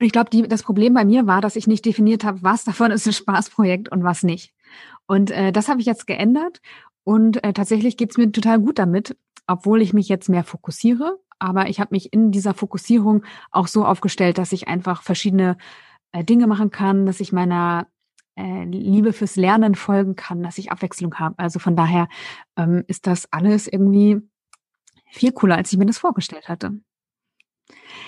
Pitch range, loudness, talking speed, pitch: 185-220 Hz, -19 LUFS, 190 wpm, 200 Hz